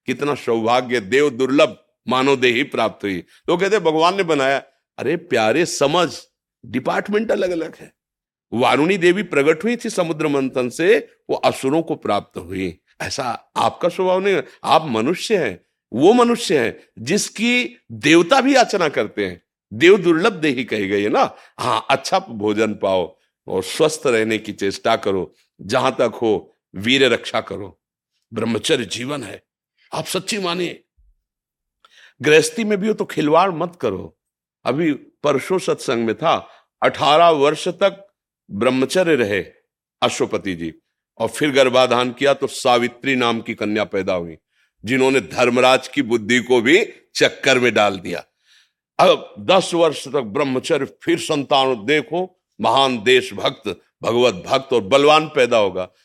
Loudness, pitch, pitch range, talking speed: -18 LUFS, 150 Hz, 125-190 Hz, 145 wpm